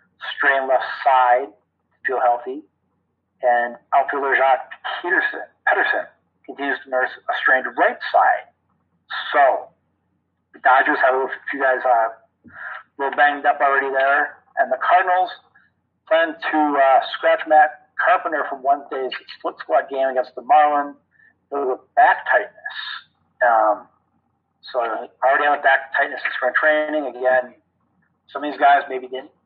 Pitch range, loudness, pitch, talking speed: 125-155 Hz, -19 LUFS, 140 Hz, 145 wpm